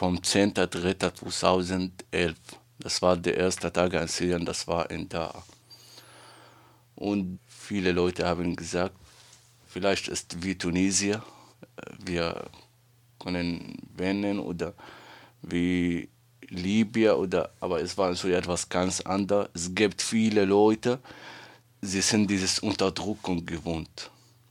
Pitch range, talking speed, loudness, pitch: 90-105 Hz, 110 wpm, -27 LUFS, 95 Hz